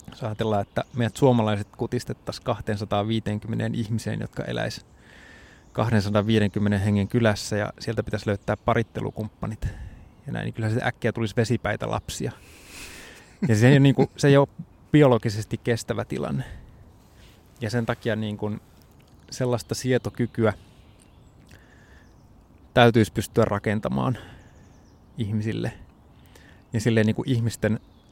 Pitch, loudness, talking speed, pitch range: 110 Hz, -25 LUFS, 115 wpm, 105-120 Hz